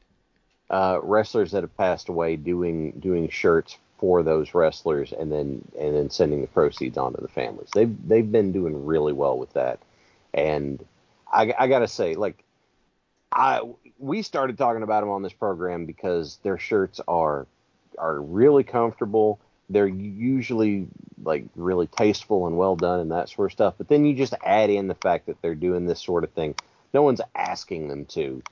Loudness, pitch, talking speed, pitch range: -24 LUFS, 95 Hz, 180 wpm, 80-110 Hz